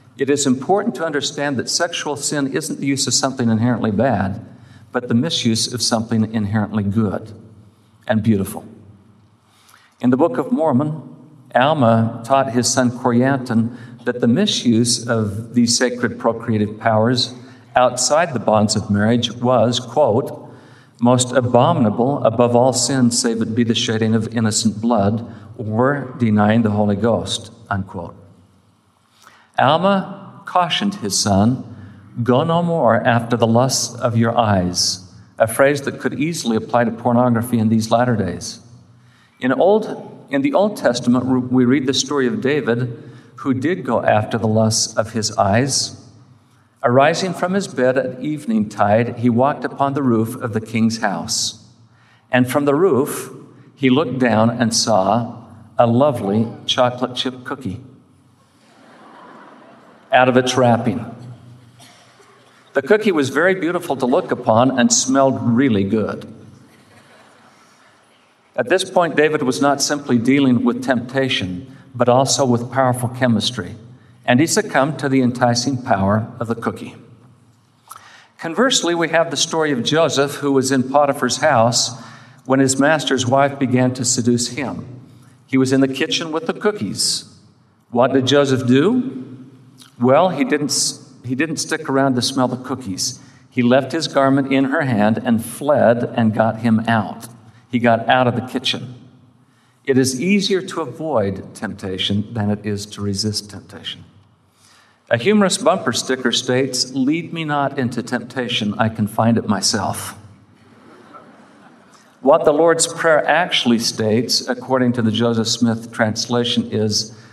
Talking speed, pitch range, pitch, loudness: 145 wpm, 115-135 Hz, 125 Hz, -17 LUFS